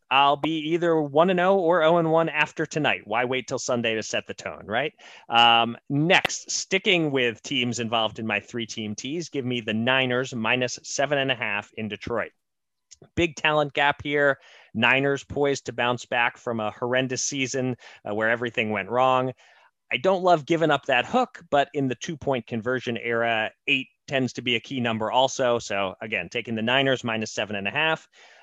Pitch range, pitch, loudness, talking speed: 115-145 Hz, 130 Hz, -24 LUFS, 195 wpm